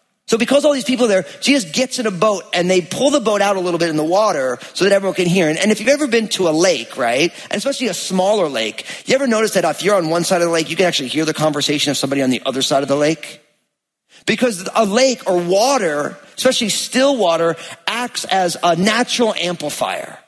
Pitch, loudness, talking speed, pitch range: 190 Hz, -16 LUFS, 250 wpm, 165-230 Hz